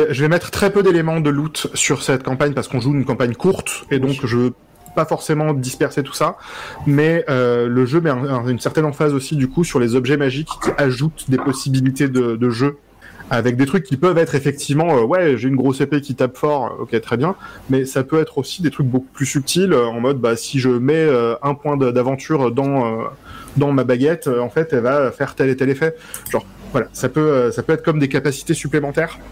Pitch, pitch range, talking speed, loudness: 140 Hz, 130-155 Hz, 235 wpm, -18 LUFS